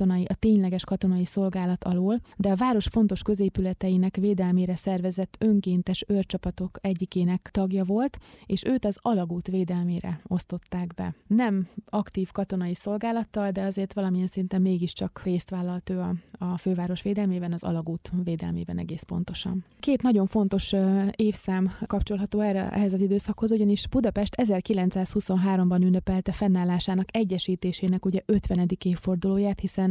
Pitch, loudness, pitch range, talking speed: 190 Hz, -26 LUFS, 180-205 Hz, 130 wpm